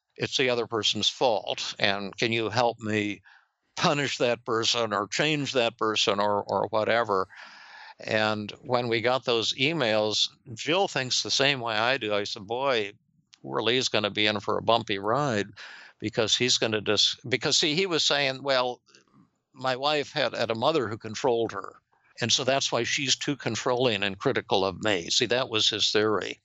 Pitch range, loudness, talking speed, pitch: 105-130 Hz, -25 LUFS, 180 wpm, 115 Hz